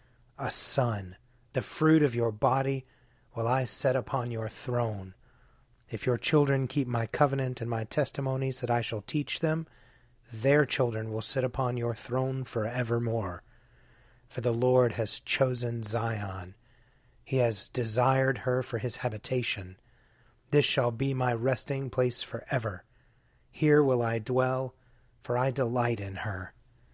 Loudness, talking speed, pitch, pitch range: -29 LUFS, 145 wpm, 125 Hz, 115-130 Hz